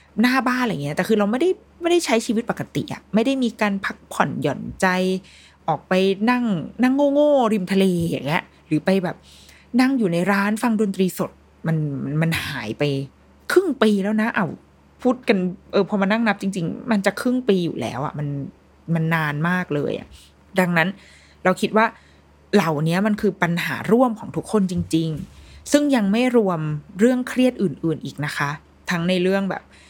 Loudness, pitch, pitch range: -21 LUFS, 195 Hz, 165-230 Hz